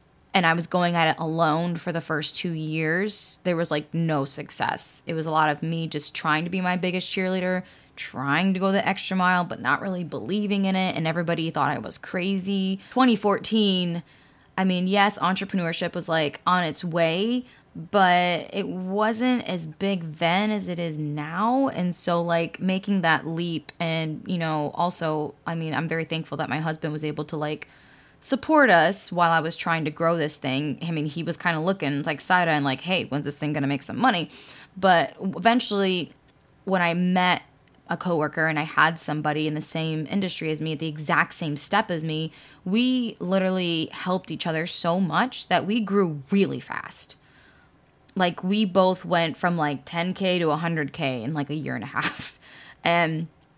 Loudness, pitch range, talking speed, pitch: -24 LUFS, 155-185 Hz, 195 wpm, 170 Hz